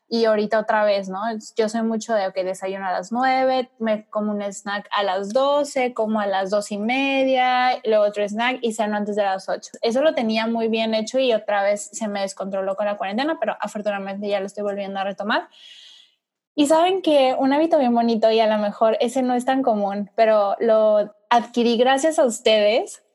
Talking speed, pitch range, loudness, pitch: 215 wpm, 205-250 Hz, -21 LUFS, 220 Hz